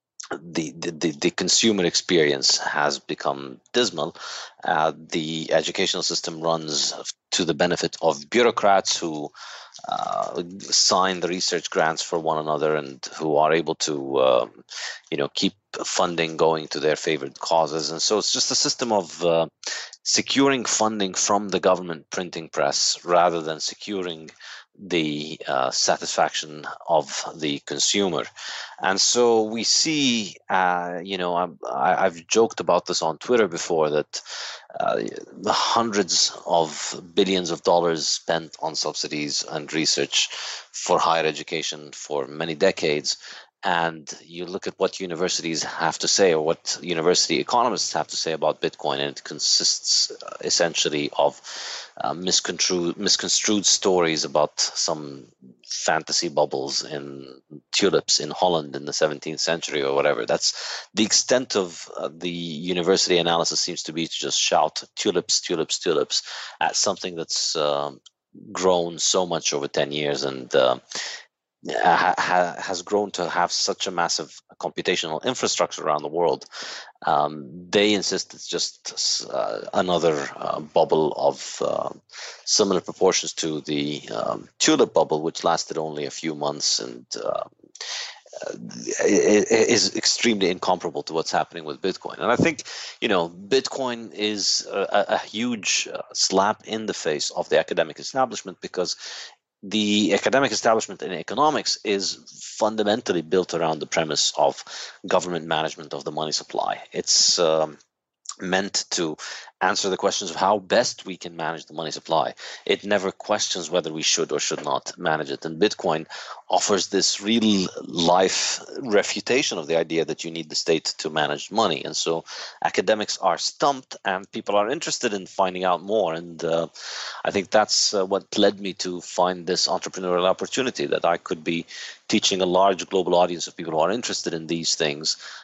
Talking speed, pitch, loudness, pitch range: 155 wpm, 85 Hz, -23 LUFS, 75-95 Hz